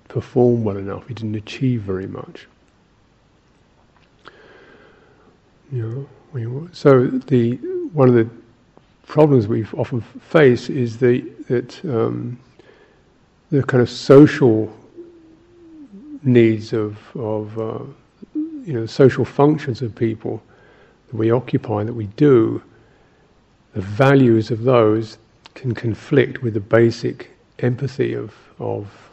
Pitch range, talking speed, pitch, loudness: 110-135 Hz, 115 wpm, 120 Hz, -18 LUFS